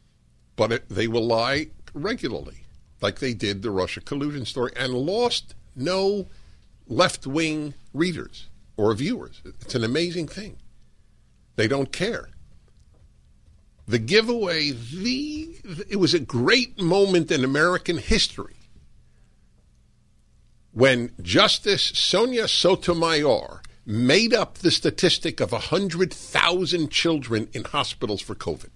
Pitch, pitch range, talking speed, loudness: 150 Hz, 120-180 Hz, 115 wpm, -23 LUFS